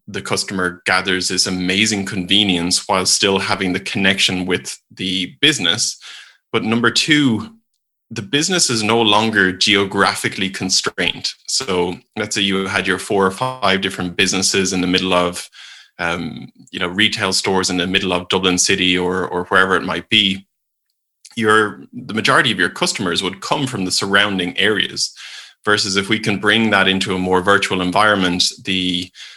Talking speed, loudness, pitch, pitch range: 165 wpm, -16 LUFS, 95 Hz, 95-105 Hz